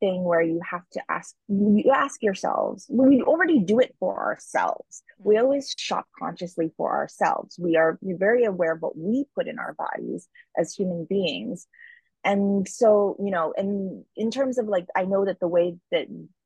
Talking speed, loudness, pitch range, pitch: 185 wpm, -24 LUFS, 180-255 Hz, 200 Hz